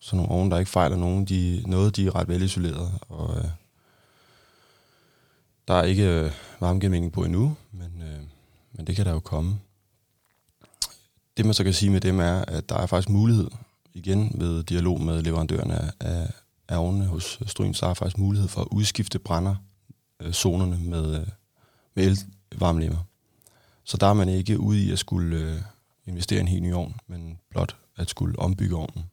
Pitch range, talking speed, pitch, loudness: 85-105 Hz, 180 wpm, 95 Hz, -25 LUFS